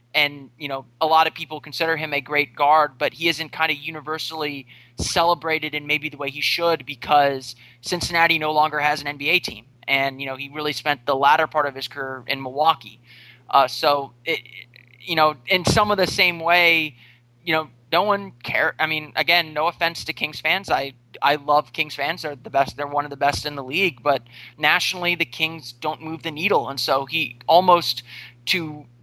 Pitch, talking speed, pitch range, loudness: 150 Hz, 205 wpm, 135-160 Hz, -21 LUFS